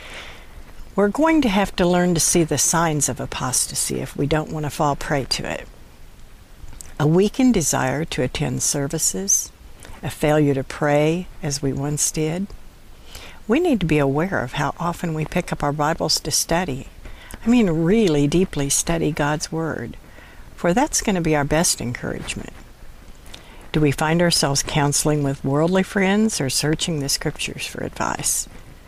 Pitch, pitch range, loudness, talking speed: 155 Hz, 145-175 Hz, -20 LUFS, 165 wpm